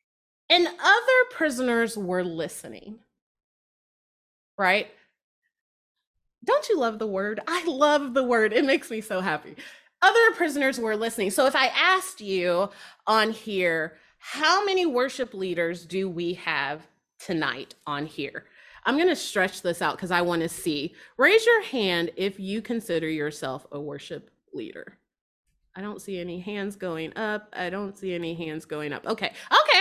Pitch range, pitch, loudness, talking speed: 175-280 Hz, 205 Hz, -25 LUFS, 155 wpm